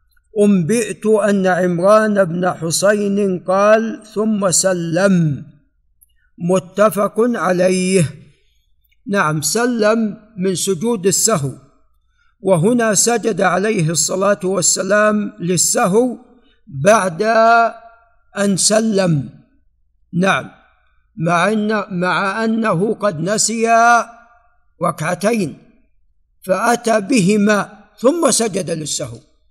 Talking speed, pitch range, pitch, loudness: 75 wpm, 180-220 Hz, 200 Hz, -15 LUFS